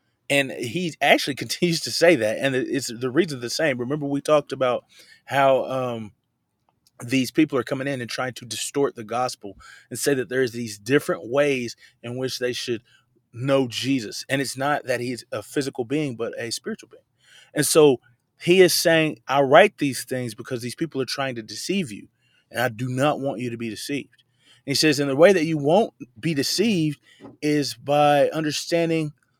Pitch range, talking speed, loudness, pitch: 120-150 Hz, 195 wpm, -22 LUFS, 135 Hz